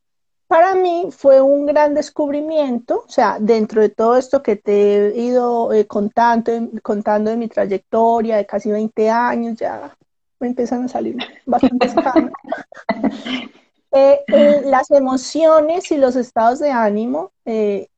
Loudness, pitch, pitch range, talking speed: -16 LUFS, 250 Hz, 220-290 Hz, 140 wpm